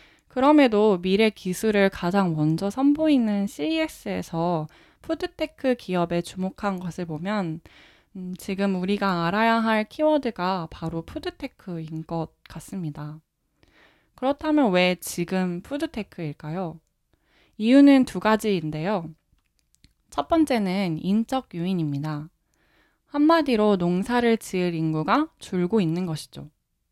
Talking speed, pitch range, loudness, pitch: 255 characters per minute, 165-230 Hz, -24 LUFS, 190 Hz